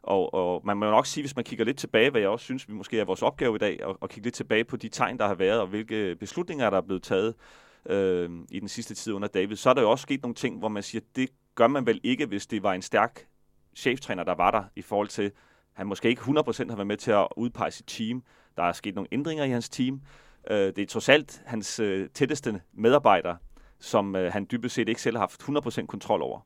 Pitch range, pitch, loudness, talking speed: 100-125 Hz, 110 Hz, -27 LUFS, 270 wpm